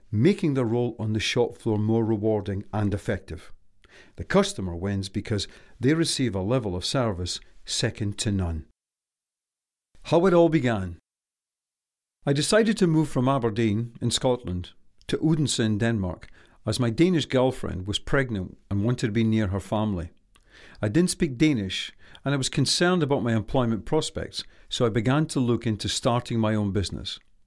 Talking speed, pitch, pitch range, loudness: 165 wpm, 115 Hz, 100-135 Hz, -25 LUFS